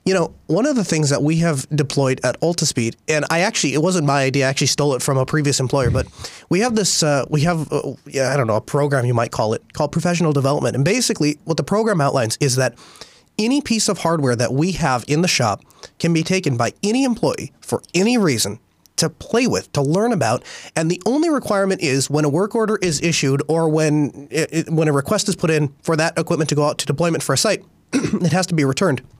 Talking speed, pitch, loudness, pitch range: 245 wpm, 155 Hz, -19 LUFS, 140-175 Hz